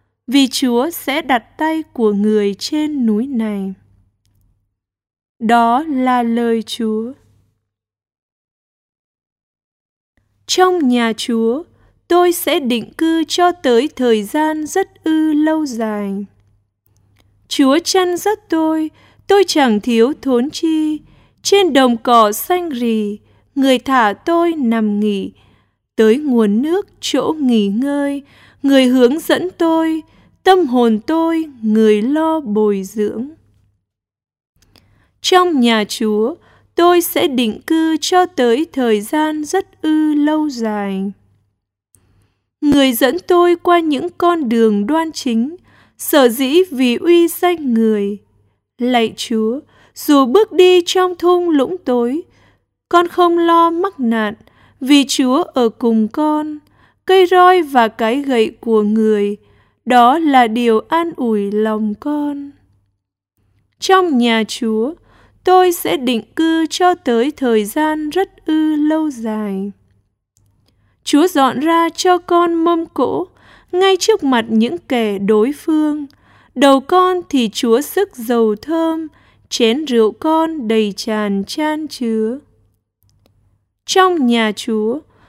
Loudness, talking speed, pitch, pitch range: -15 LUFS, 120 wpm, 255 Hz, 215-320 Hz